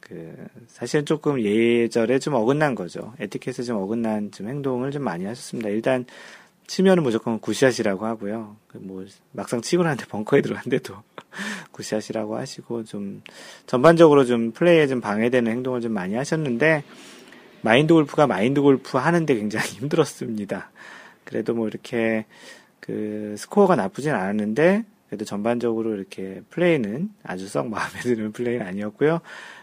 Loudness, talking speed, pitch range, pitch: -22 LUFS, 360 characters per minute, 110-150 Hz, 120 Hz